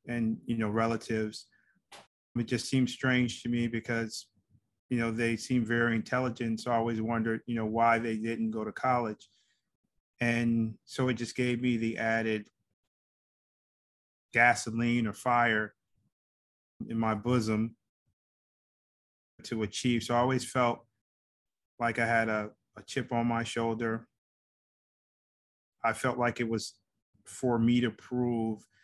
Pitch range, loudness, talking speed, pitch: 110-120 Hz, -31 LUFS, 140 wpm, 115 Hz